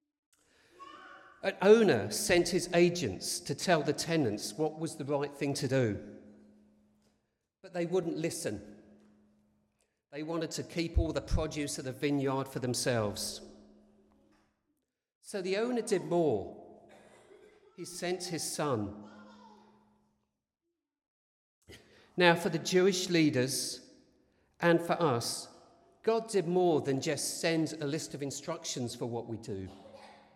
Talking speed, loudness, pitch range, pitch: 125 wpm, -32 LUFS, 125-180 Hz, 155 Hz